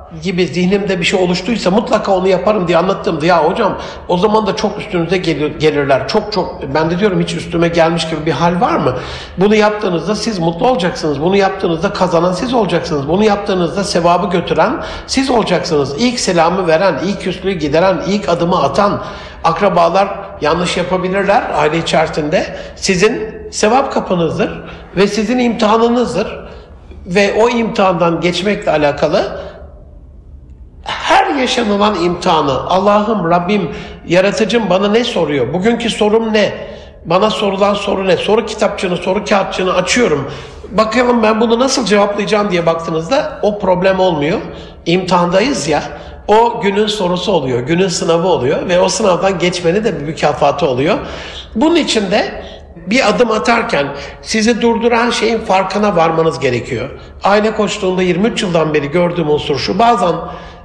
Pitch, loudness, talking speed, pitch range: 190 Hz, -13 LUFS, 140 wpm, 170-215 Hz